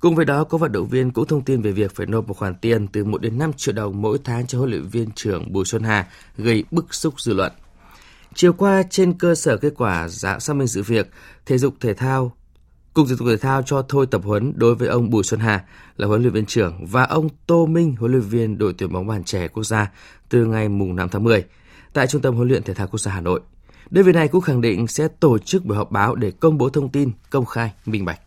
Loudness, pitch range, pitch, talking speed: -20 LUFS, 105-140 Hz, 115 Hz, 265 wpm